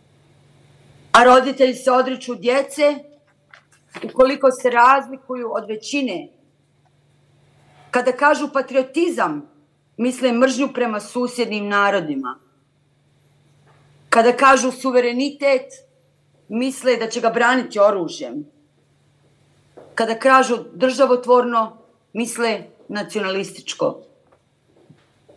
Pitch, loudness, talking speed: 235 Hz, -18 LUFS, 75 wpm